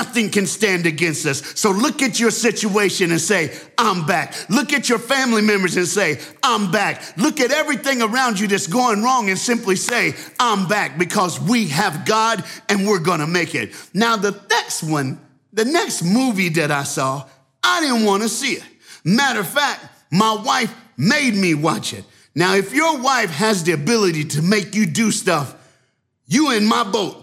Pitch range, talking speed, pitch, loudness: 165-230 Hz, 190 wpm, 205 Hz, -18 LUFS